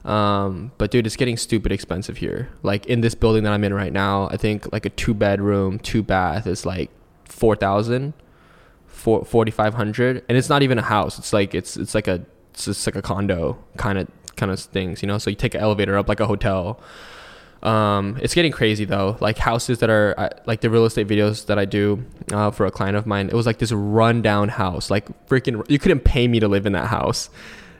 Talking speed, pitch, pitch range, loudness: 225 wpm, 105 Hz, 100-115 Hz, -21 LUFS